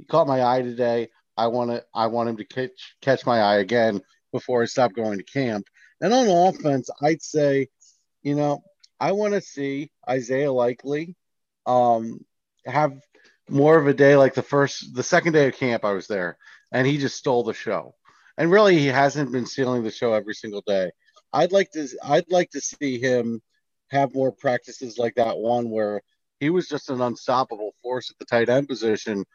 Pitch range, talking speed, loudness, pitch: 120-145 Hz, 195 wpm, -22 LUFS, 130 Hz